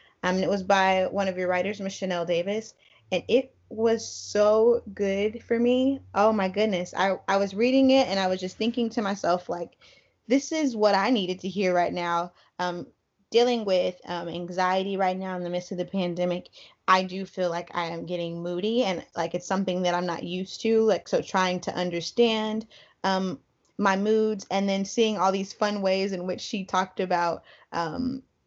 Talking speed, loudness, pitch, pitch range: 200 wpm, -26 LUFS, 190 Hz, 180-215 Hz